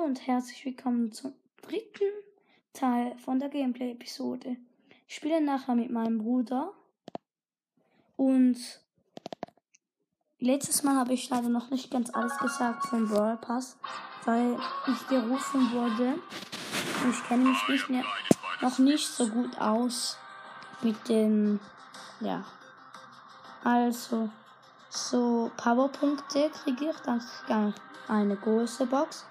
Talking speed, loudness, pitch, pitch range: 115 wpm, -29 LUFS, 250 Hz, 235-275 Hz